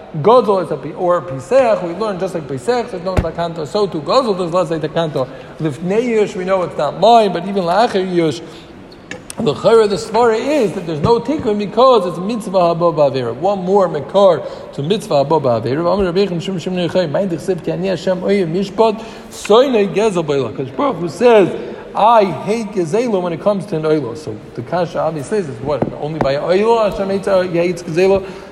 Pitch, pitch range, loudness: 185 Hz, 160-205 Hz, -15 LUFS